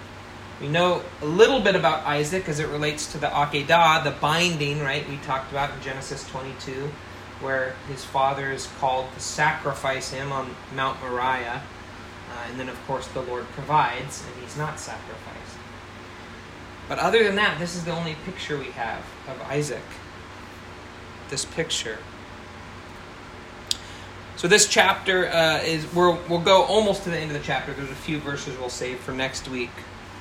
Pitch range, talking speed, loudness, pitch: 125-155 Hz, 165 wpm, -24 LUFS, 135 Hz